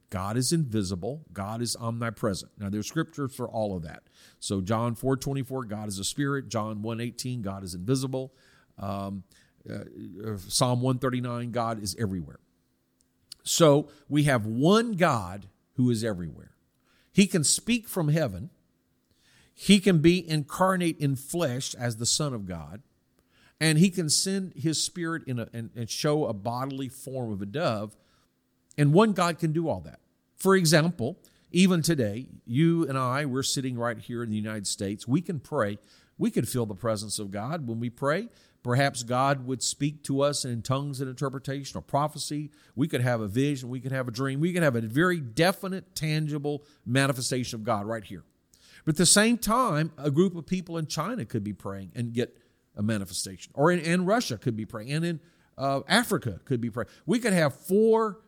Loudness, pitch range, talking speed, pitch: -27 LUFS, 115-160 Hz, 180 wpm, 130 Hz